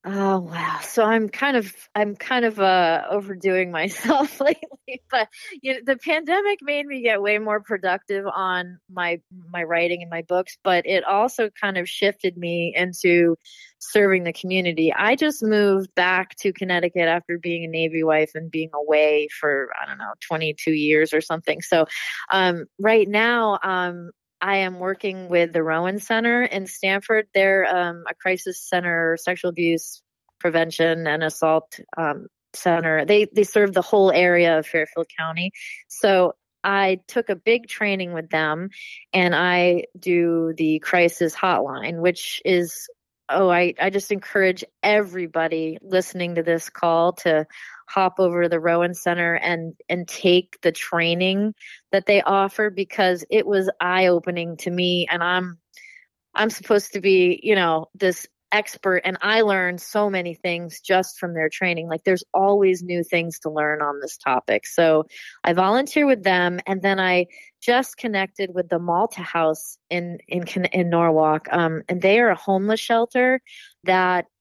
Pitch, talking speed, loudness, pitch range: 180 Hz, 165 wpm, -21 LUFS, 170-200 Hz